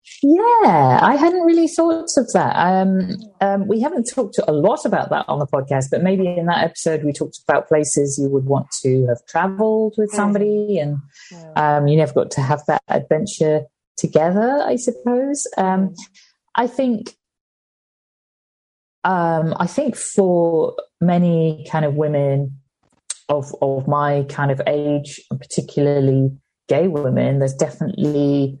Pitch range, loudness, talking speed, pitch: 145-210 Hz, -18 LUFS, 150 wpm, 165 Hz